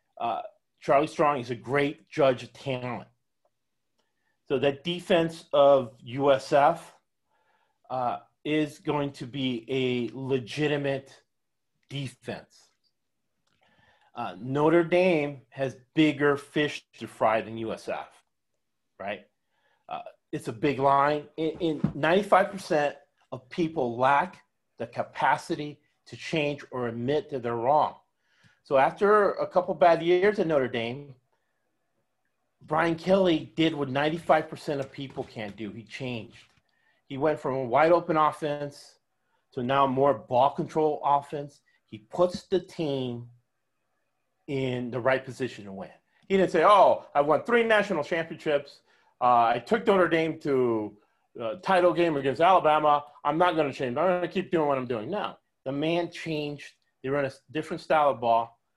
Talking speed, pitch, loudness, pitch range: 145 wpm, 145 Hz, -26 LUFS, 130-165 Hz